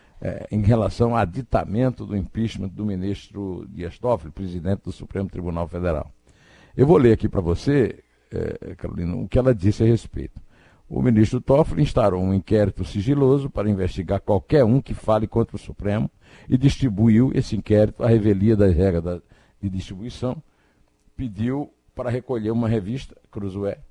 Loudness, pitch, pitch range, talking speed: -22 LUFS, 105 Hz, 95-120 Hz, 155 wpm